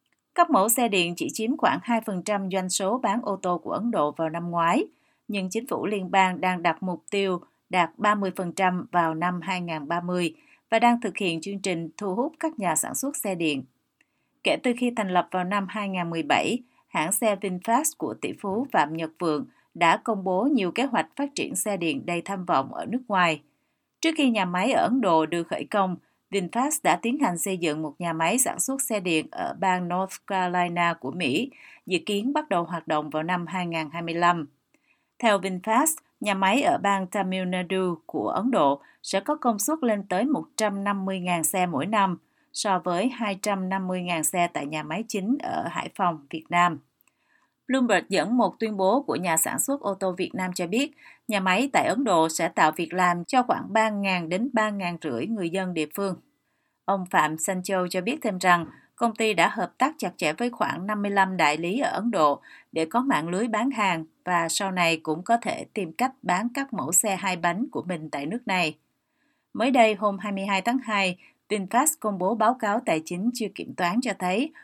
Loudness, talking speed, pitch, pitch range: -25 LUFS, 200 wpm, 195 Hz, 175-235 Hz